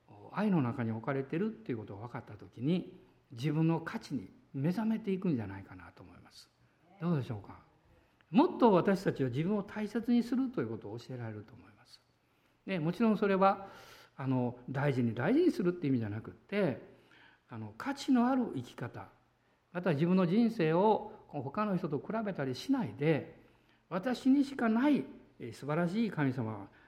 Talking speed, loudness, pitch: 355 characters per minute, -33 LUFS, 160 Hz